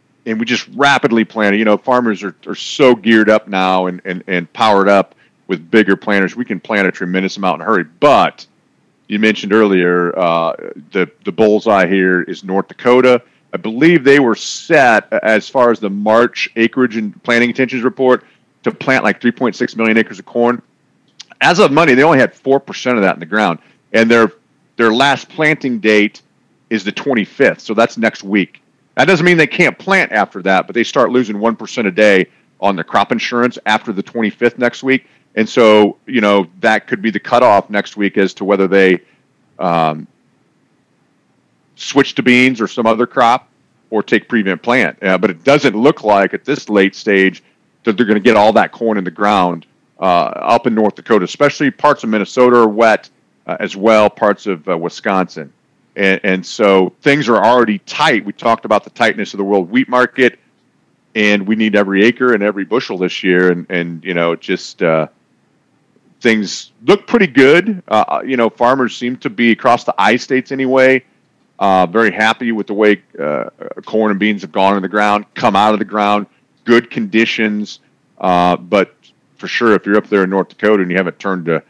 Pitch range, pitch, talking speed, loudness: 95-120 Hz, 110 Hz, 200 wpm, -13 LUFS